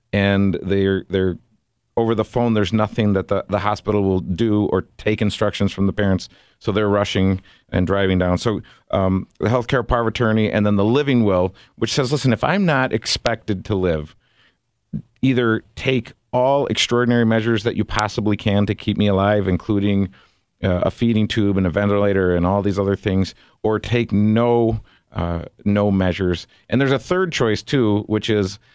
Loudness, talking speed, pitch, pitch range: -19 LUFS, 180 wpm, 105 Hz, 95-115 Hz